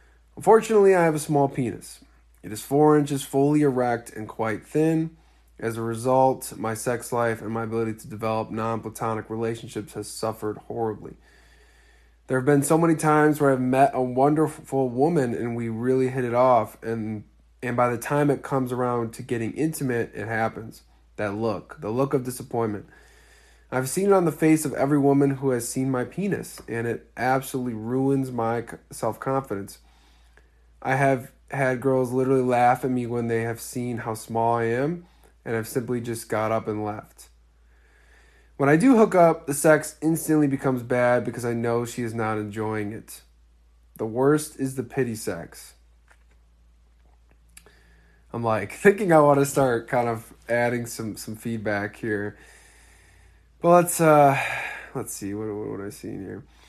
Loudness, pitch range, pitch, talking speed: -24 LUFS, 110-135 Hz, 120 Hz, 170 wpm